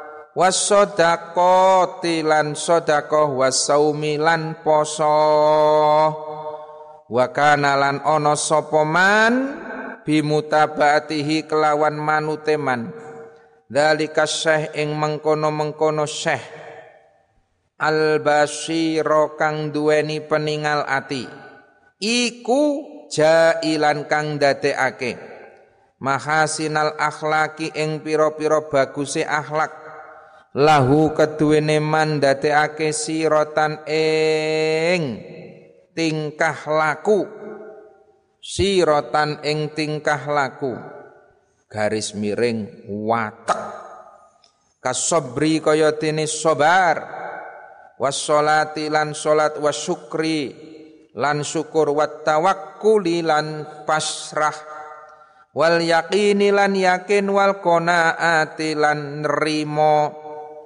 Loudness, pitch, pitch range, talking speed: -19 LUFS, 155 Hz, 150-155 Hz, 65 wpm